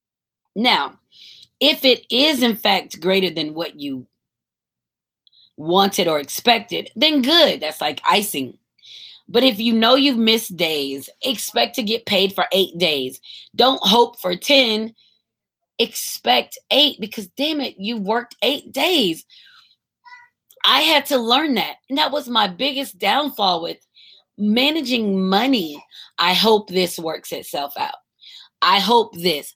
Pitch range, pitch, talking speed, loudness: 180-265 Hz, 225 Hz, 140 wpm, -18 LUFS